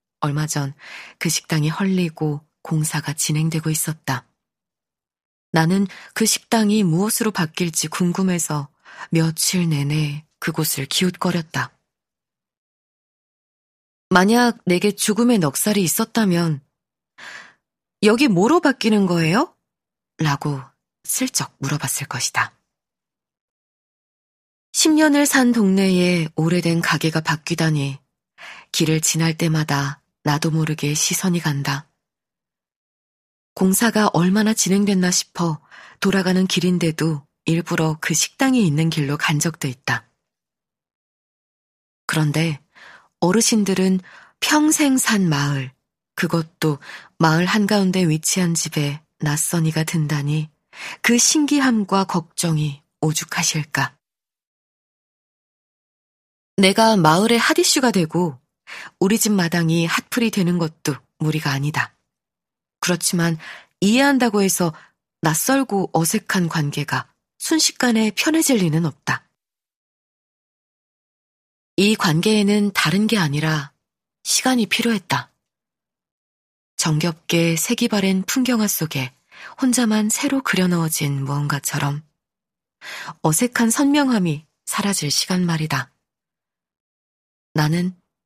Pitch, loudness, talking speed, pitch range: 170 Hz, -19 LUFS, 220 characters per minute, 155-205 Hz